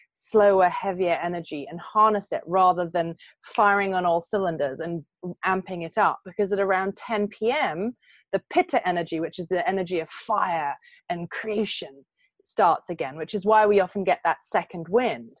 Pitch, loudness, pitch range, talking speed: 190 Hz, -25 LUFS, 170-215 Hz, 170 wpm